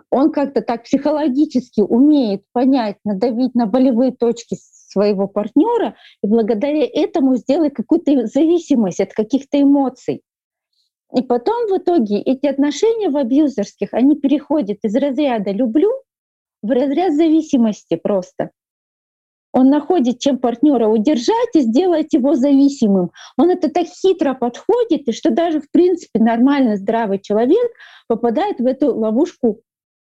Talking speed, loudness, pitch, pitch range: 125 wpm, -16 LUFS, 270 Hz, 230-305 Hz